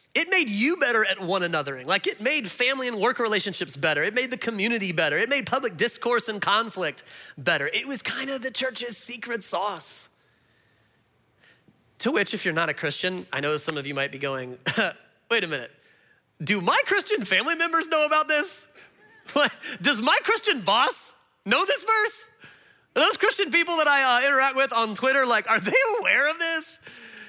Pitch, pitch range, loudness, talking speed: 245 Hz, 200-310 Hz, -23 LUFS, 190 wpm